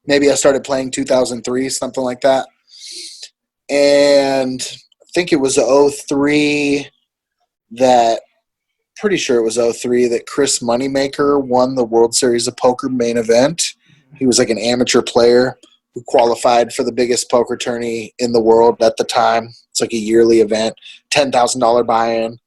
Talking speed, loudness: 160 wpm, -15 LUFS